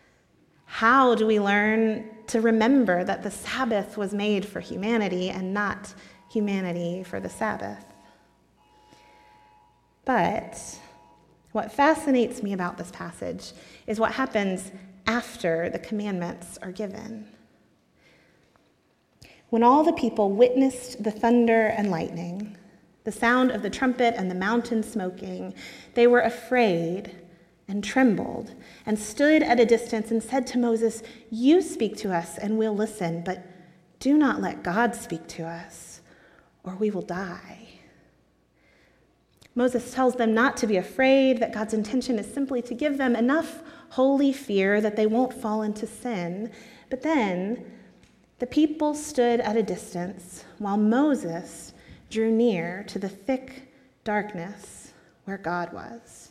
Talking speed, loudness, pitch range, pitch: 135 wpm, -25 LUFS, 185-240 Hz, 220 Hz